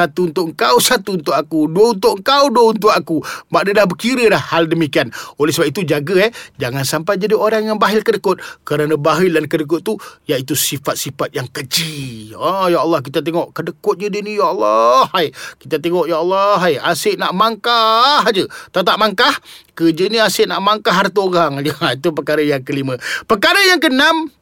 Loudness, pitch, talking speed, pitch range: -15 LUFS, 175 Hz, 190 wpm, 155-215 Hz